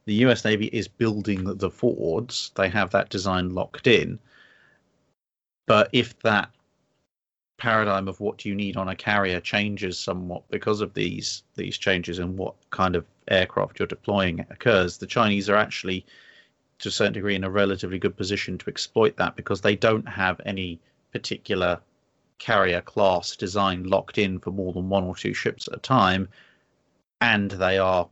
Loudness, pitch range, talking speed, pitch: -24 LUFS, 95-105 Hz, 170 wpm, 95 Hz